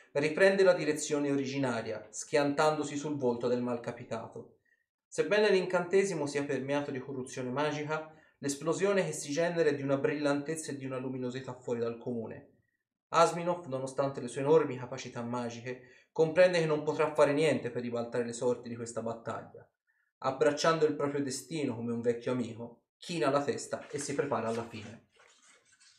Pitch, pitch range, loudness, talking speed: 140 Hz, 120-155 Hz, -32 LUFS, 155 wpm